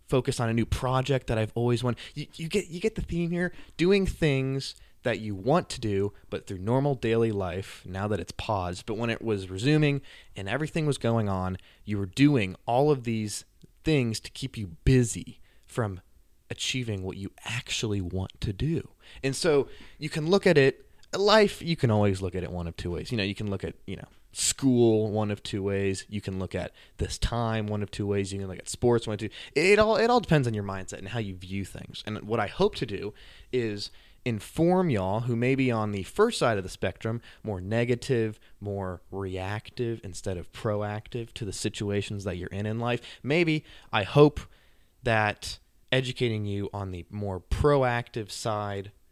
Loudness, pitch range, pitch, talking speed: -28 LUFS, 95-130 Hz, 110 Hz, 205 wpm